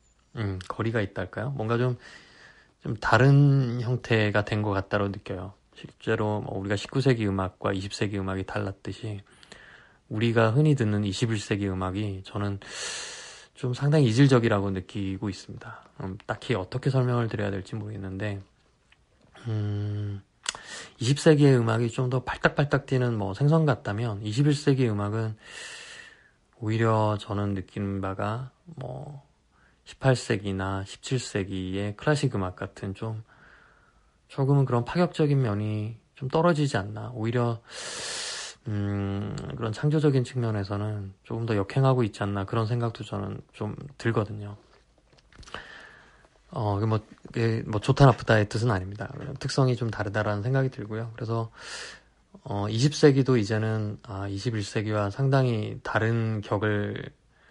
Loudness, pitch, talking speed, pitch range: -27 LUFS, 110 Hz, 265 characters per minute, 100-130 Hz